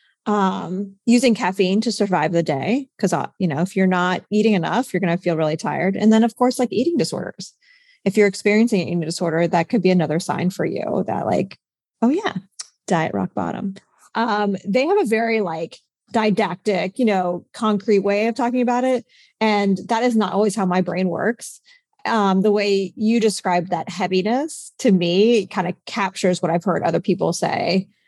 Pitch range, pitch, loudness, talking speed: 180-230 Hz, 200 Hz, -20 LUFS, 190 wpm